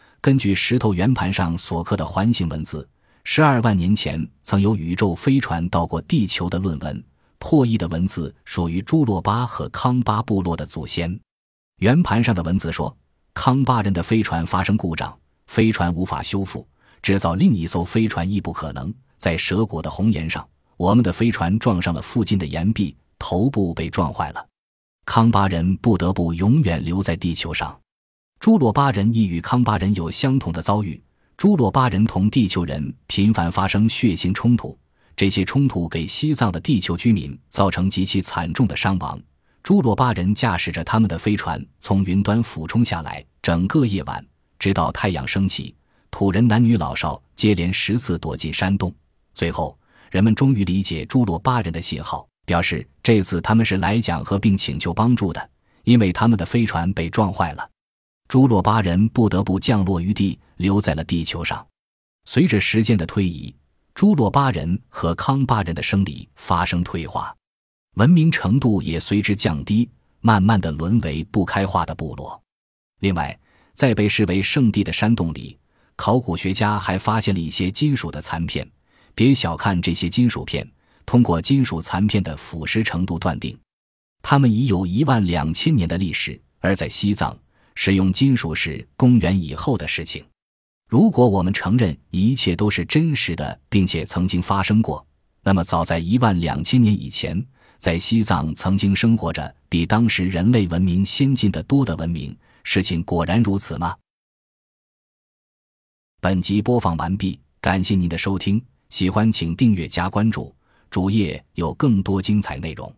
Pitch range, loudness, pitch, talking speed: 85-110 Hz, -20 LUFS, 95 Hz, 255 characters per minute